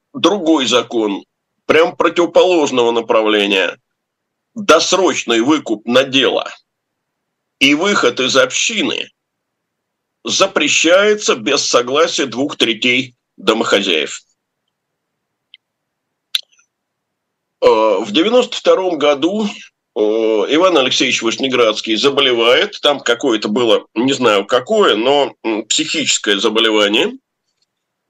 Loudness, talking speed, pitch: -13 LUFS, 75 wpm, 170 Hz